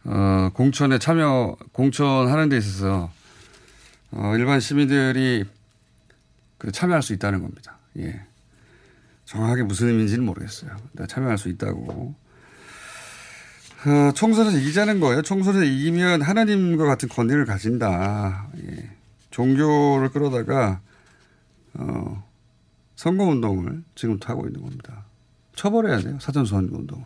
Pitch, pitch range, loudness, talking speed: 125 Hz, 105-145 Hz, -21 LUFS, 275 characters per minute